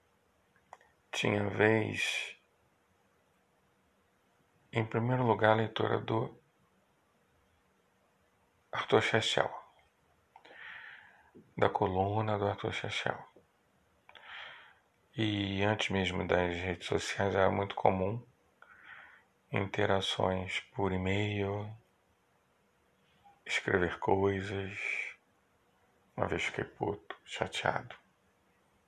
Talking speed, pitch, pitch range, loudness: 75 wpm, 100 Hz, 95-105 Hz, -33 LUFS